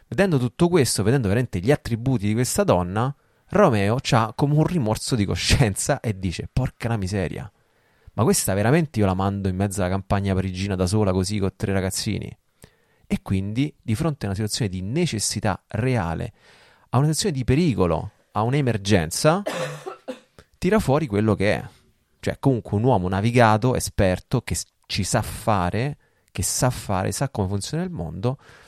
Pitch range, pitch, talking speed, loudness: 95-135 Hz, 110 Hz, 165 wpm, -23 LUFS